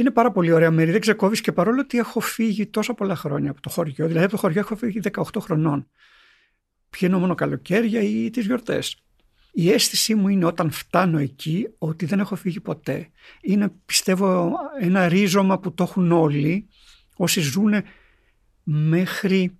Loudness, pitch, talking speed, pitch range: -21 LUFS, 190 Hz, 170 wpm, 170-215 Hz